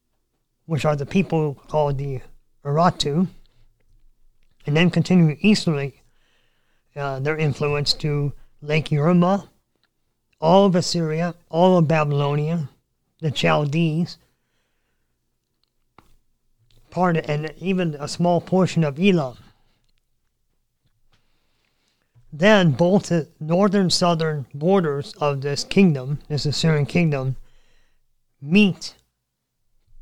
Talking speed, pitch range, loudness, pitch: 95 wpm, 140-170 Hz, -20 LUFS, 155 Hz